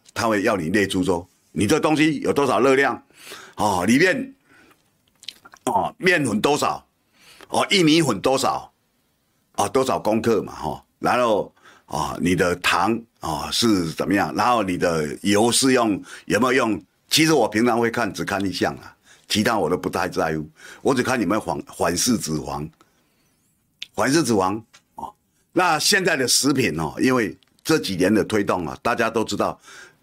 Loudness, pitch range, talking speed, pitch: -21 LUFS, 95-130 Hz, 240 characters per minute, 110 Hz